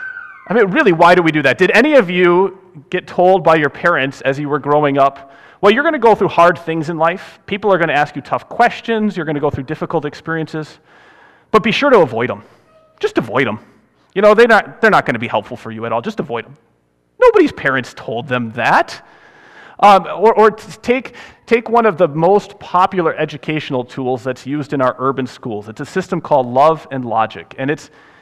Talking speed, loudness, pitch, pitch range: 225 wpm, -14 LUFS, 170 Hz, 140-210 Hz